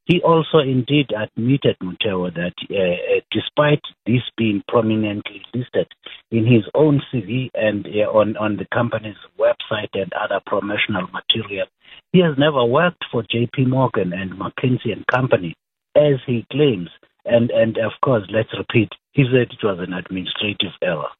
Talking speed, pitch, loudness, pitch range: 155 wpm, 115 Hz, -19 LUFS, 105-140 Hz